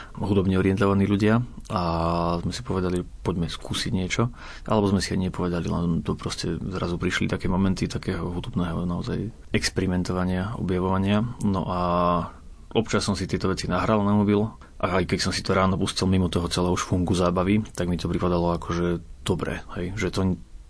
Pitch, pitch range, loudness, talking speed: 90 Hz, 85-100 Hz, -25 LUFS, 170 wpm